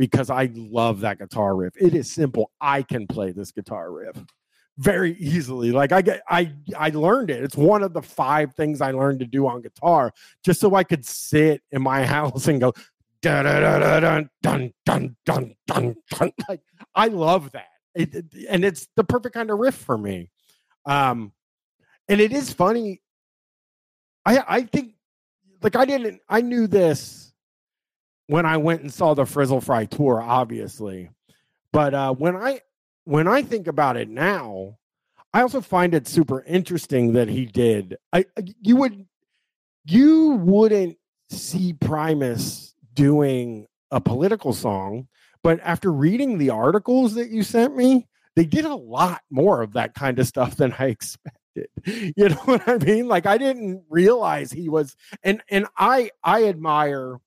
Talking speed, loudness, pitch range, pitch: 165 wpm, -21 LUFS, 130-200 Hz, 155 Hz